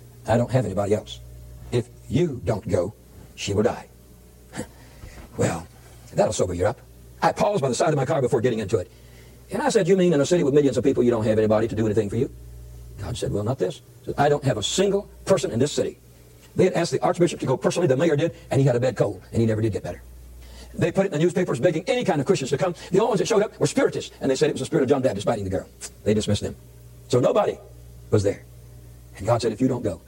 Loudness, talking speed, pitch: -23 LUFS, 270 wpm, 115 Hz